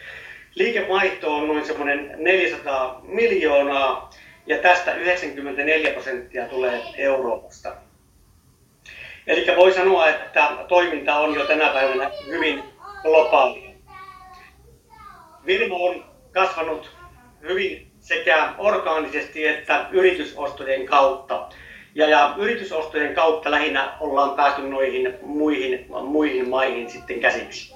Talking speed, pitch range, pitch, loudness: 95 wpm, 140-190 Hz, 155 Hz, -20 LUFS